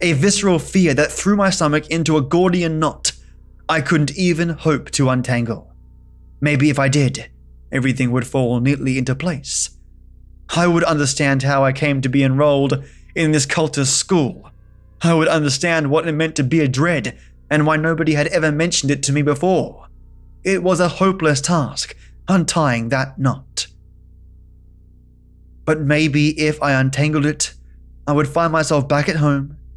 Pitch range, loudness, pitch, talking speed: 125-160 Hz, -17 LUFS, 145 Hz, 165 wpm